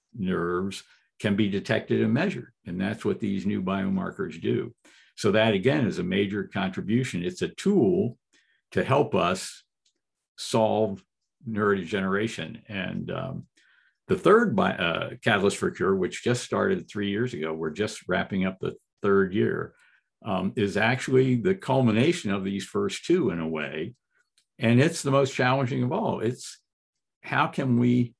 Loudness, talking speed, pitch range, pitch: -26 LUFS, 155 wpm, 100-130 Hz, 110 Hz